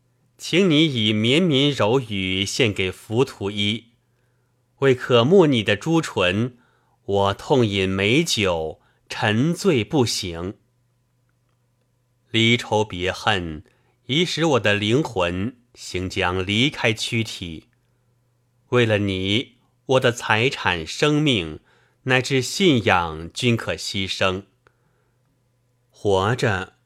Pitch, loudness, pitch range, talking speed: 120 Hz, -20 LUFS, 100-125 Hz, 140 characters per minute